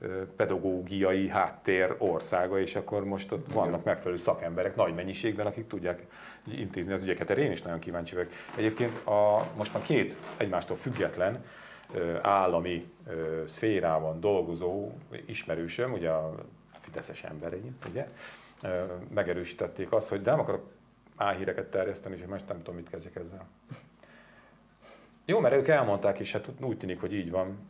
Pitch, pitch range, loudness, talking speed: 95 Hz, 85-100 Hz, -31 LUFS, 140 wpm